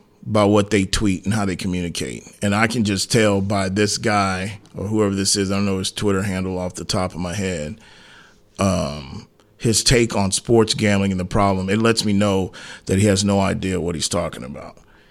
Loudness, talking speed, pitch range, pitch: -20 LUFS, 215 wpm, 95-105 Hz, 100 Hz